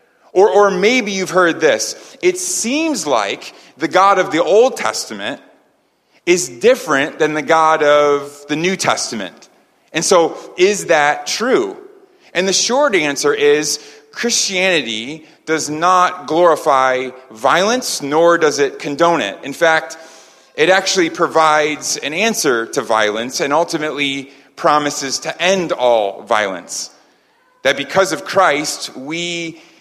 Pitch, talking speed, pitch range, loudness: 165 Hz, 130 wpm, 145-195 Hz, -15 LUFS